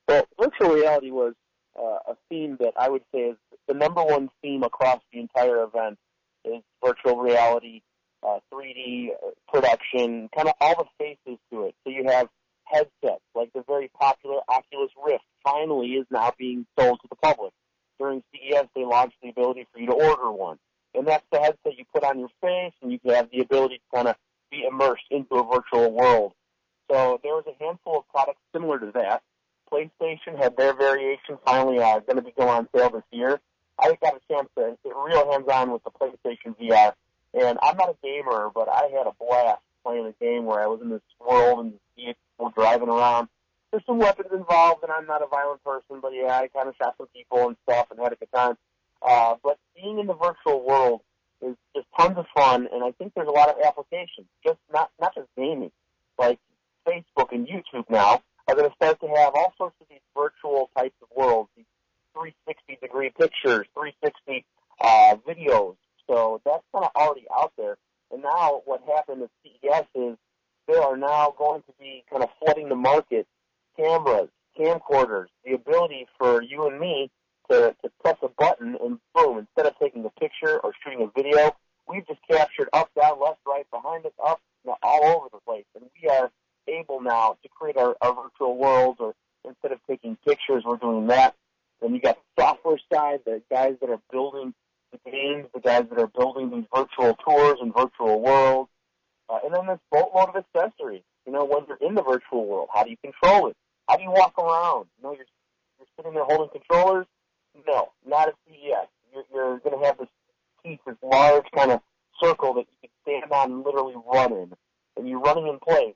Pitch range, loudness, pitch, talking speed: 125-170 Hz, -23 LUFS, 140 Hz, 205 wpm